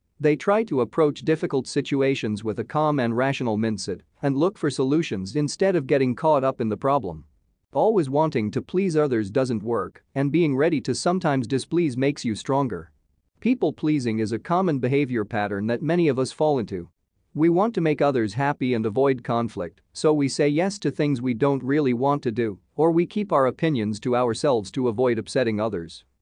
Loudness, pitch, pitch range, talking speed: -23 LUFS, 135 Hz, 115-155 Hz, 195 wpm